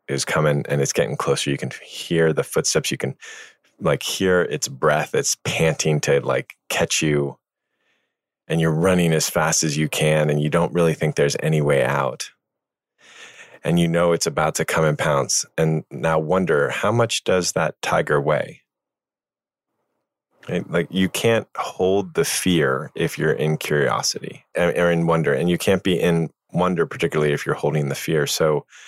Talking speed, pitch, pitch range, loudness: 180 wpm, 80 Hz, 75-85 Hz, -20 LUFS